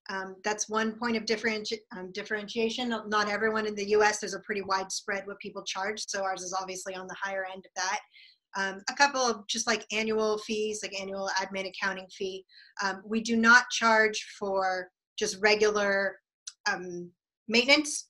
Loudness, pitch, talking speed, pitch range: -29 LUFS, 210 Hz, 175 wpm, 190-220 Hz